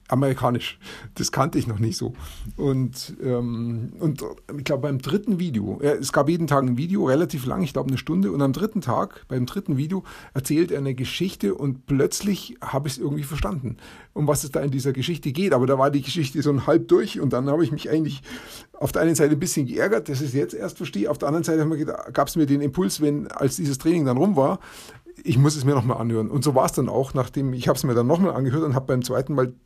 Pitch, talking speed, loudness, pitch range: 145 Hz, 250 wpm, -23 LUFS, 130-160 Hz